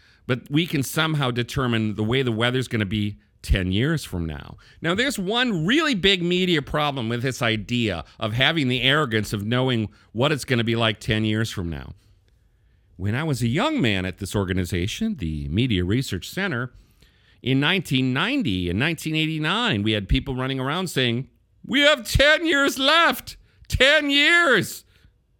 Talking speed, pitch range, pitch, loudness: 165 wpm, 105-155 Hz, 120 Hz, -22 LUFS